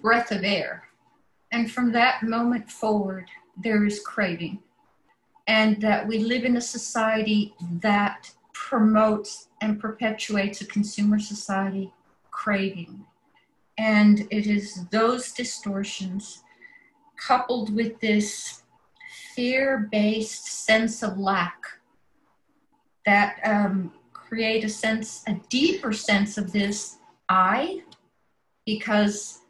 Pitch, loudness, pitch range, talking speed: 215 Hz, -24 LUFS, 205-235 Hz, 105 wpm